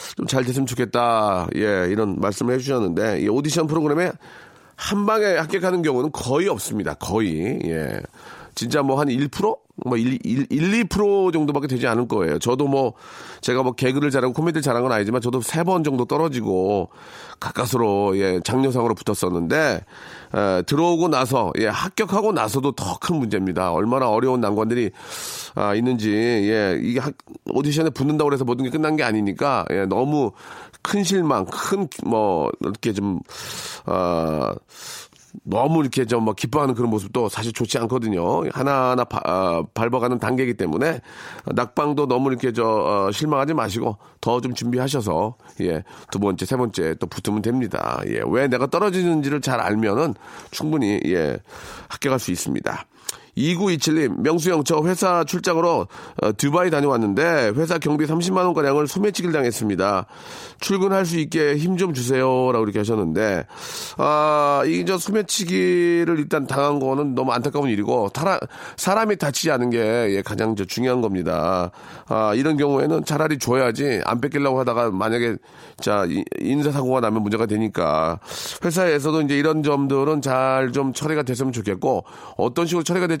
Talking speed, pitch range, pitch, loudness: 335 characters per minute, 115-160 Hz, 135 Hz, -21 LUFS